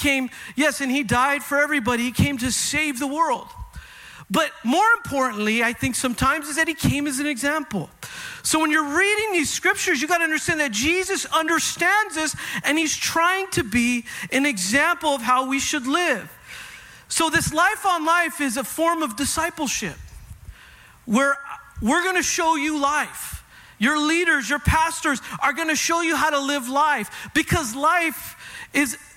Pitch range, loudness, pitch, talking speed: 275-335 Hz, -21 LUFS, 300 Hz, 175 wpm